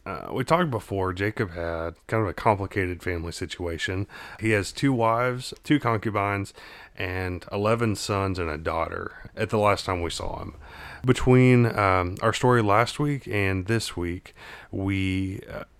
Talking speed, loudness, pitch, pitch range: 160 wpm, -25 LUFS, 100 Hz, 95-115 Hz